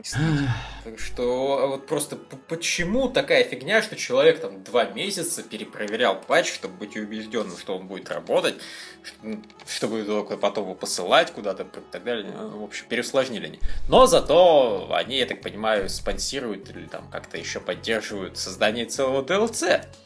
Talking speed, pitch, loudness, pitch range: 150 wpm, 135 Hz, -23 LUFS, 115-185 Hz